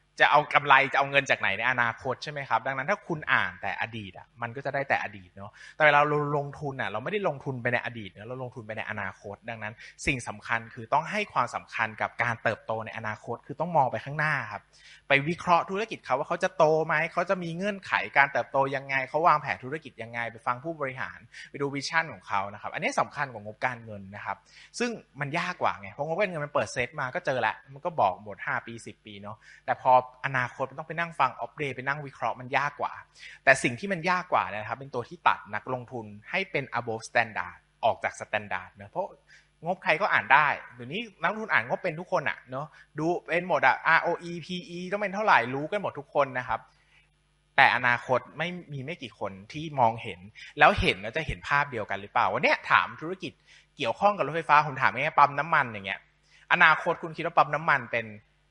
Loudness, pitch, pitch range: -27 LUFS, 140 Hz, 115-165 Hz